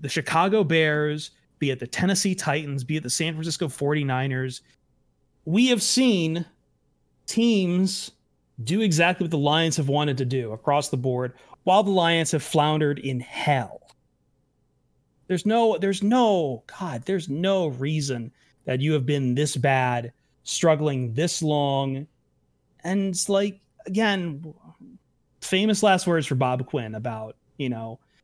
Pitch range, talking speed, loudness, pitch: 135-185 Hz, 140 wpm, -24 LUFS, 150 Hz